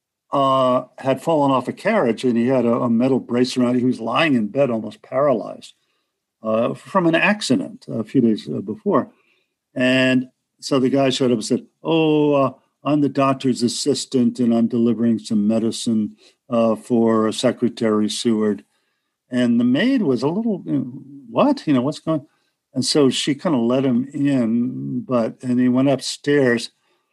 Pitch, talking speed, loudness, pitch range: 125 Hz, 175 wpm, -19 LUFS, 115-140 Hz